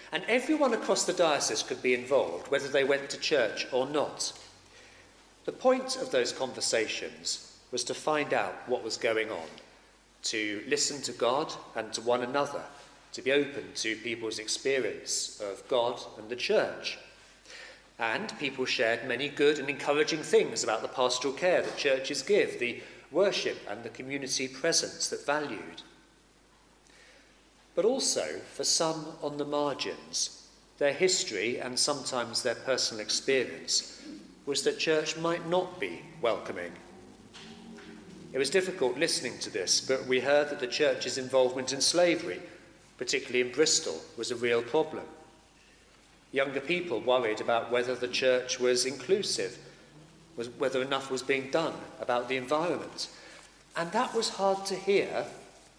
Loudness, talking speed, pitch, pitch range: -30 LUFS, 145 wpm, 145 Hz, 130-185 Hz